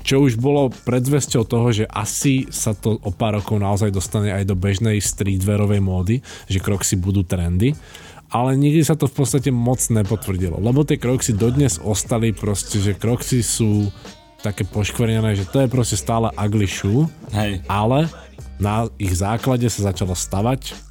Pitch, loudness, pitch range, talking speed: 110 Hz, -19 LUFS, 100-125 Hz, 160 wpm